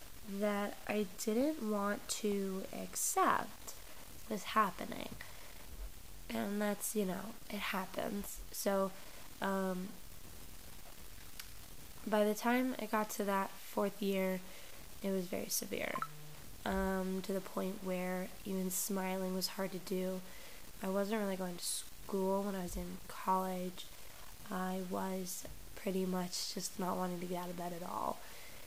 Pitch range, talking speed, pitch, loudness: 185-210 Hz, 135 wpm, 195 Hz, -38 LUFS